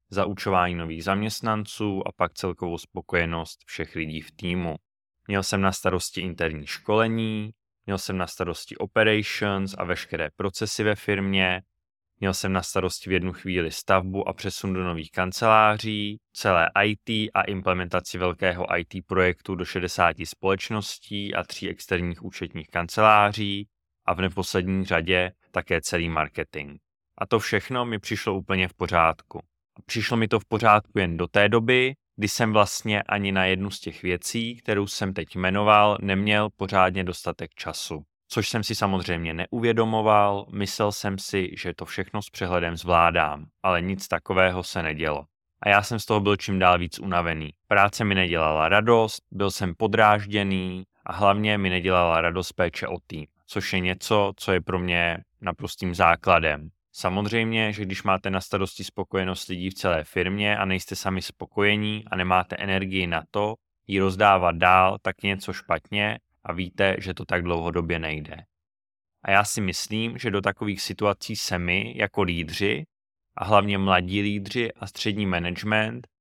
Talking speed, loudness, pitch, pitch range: 160 wpm, -24 LUFS, 95 Hz, 90-105 Hz